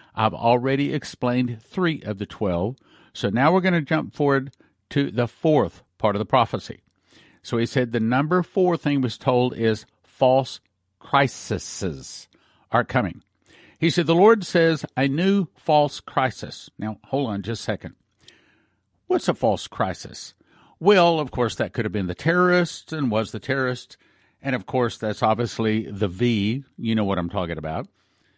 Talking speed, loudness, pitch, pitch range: 170 wpm, -23 LUFS, 125 Hz, 105-150 Hz